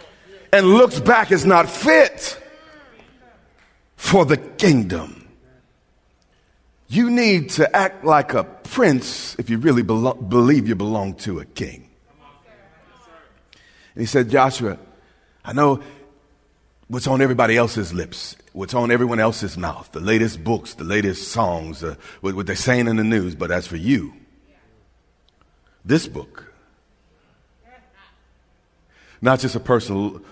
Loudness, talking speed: -18 LUFS, 130 wpm